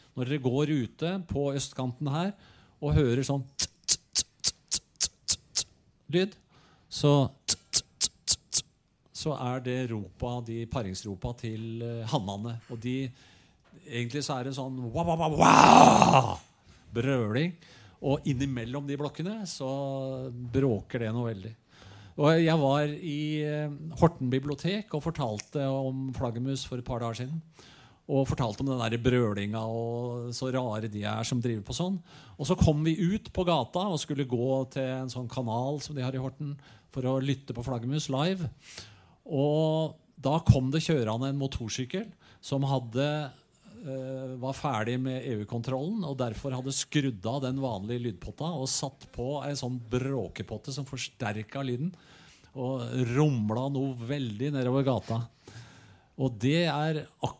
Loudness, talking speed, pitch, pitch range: -29 LUFS, 135 wpm, 130 Hz, 120-145 Hz